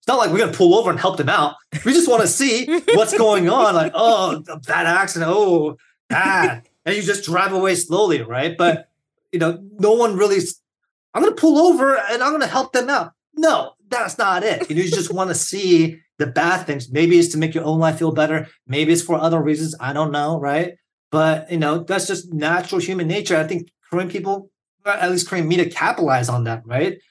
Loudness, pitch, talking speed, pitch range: -18 LUFS, 175 Hz, 225 wpm, 160-195 Hz